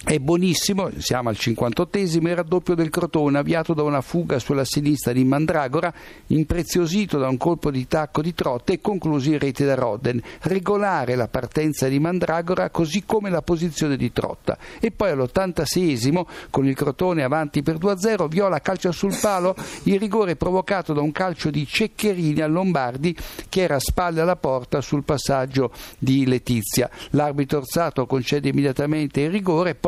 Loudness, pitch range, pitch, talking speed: -22 LUFS, 140-180 Hz, 155 Hz, 165 wpm